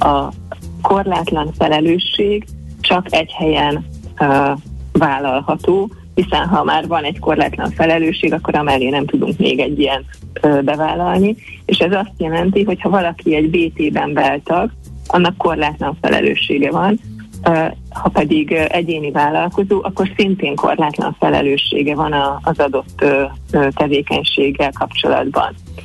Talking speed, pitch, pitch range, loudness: 130 wpm, 150 Hz, 135-170 Hz, -16 LUFS